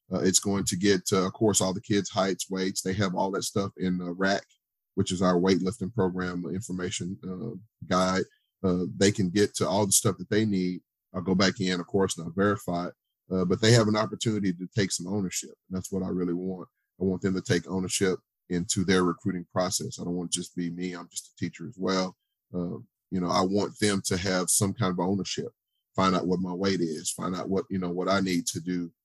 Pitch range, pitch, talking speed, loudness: 90-100 Hz, 95 Hz, 245 wpm, -28 LUFS